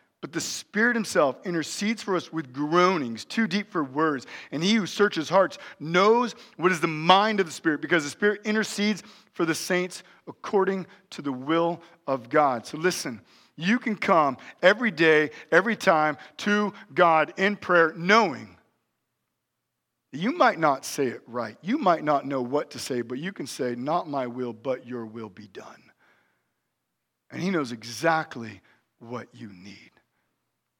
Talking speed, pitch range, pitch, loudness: 170 wpm, 140-195 Hz, 170 Hz, -25 LUFS